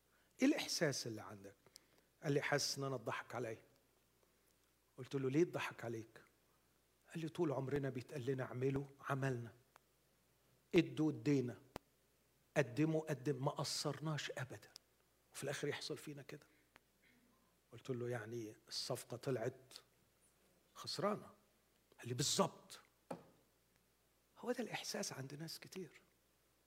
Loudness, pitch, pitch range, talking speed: -42 LUFS, 135 Hz, 120-150 Hz, 115 wpm